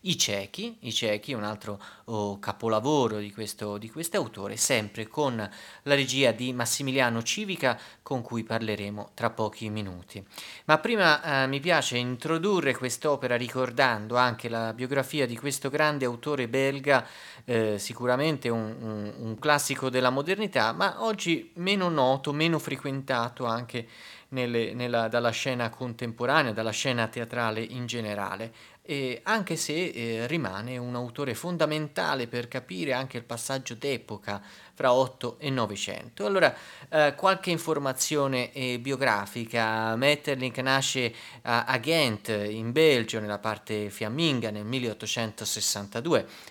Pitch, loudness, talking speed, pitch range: 125 Hz, -28 LUFS, 130 wpm, 110-140 Hz